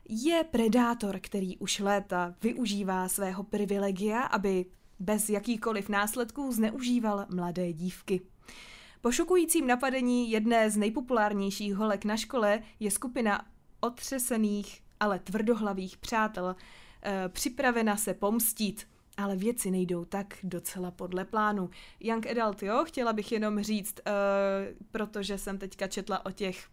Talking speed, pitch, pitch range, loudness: 125 wpm, 205 Hz, 195-230 Hz, -31 LUFS